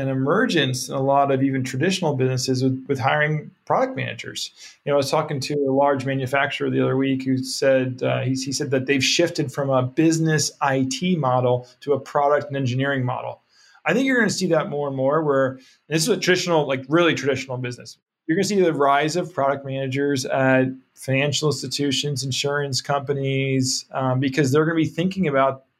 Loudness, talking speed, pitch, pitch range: -21 LUFS, 205 wpm, 140 Hz, 130-150 Hz